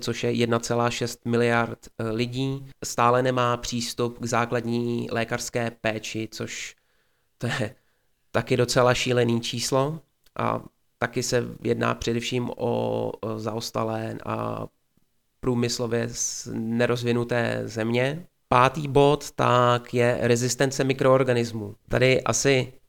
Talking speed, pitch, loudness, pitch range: 100 wpm, 120 Hz, -25 LUFS, 115-125 Hz